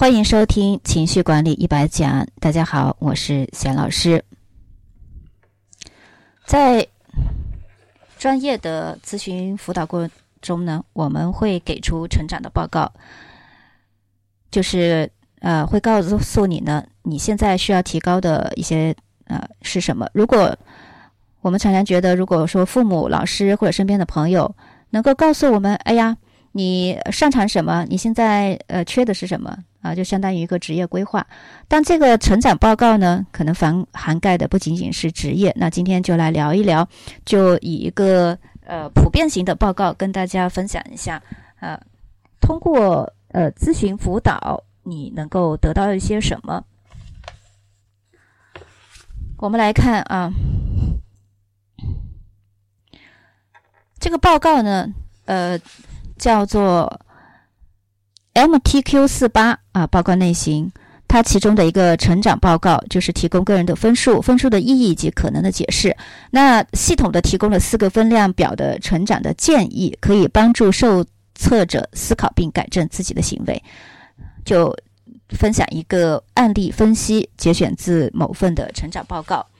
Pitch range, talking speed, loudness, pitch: 145-205 Hz, 220 characters per minute, -17 LUFS, 180 Hz